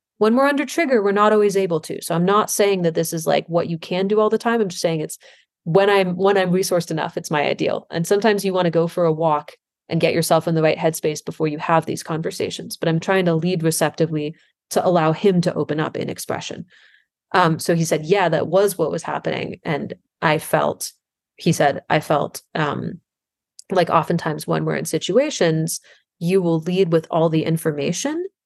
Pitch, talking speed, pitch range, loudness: 170 Hz, 215 wpm, 160-195 Hz, -20 LUFS